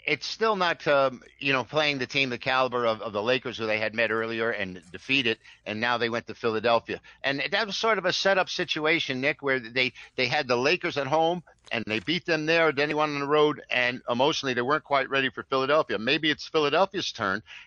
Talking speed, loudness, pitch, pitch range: 235 wpm, -26 LUFS, 135 Hz, 120-155 Hz